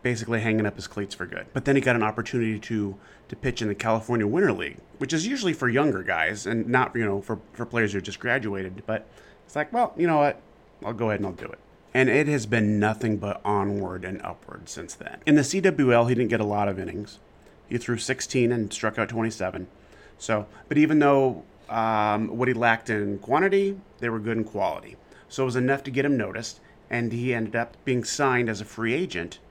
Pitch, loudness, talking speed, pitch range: 115 Hz, -25 LUFS, 230 wpm, 105-130 Hz